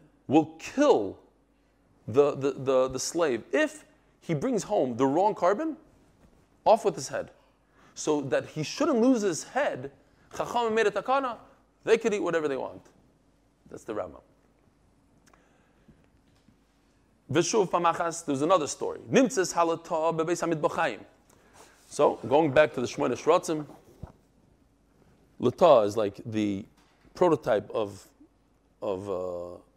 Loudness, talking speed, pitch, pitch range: -27 LUFS, 105 wpm, 165 Hz, 140-215 Hz